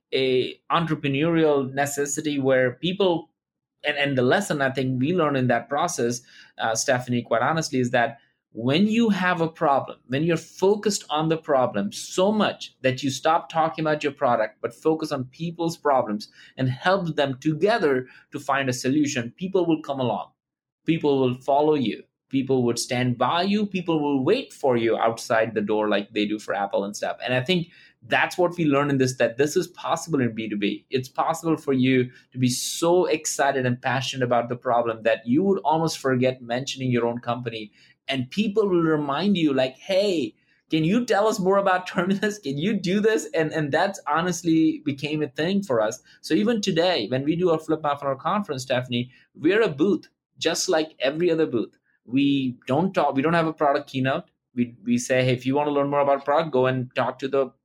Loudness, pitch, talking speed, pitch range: -23 LUFS, 145 Hz, 200 wpm, 130-165 Hz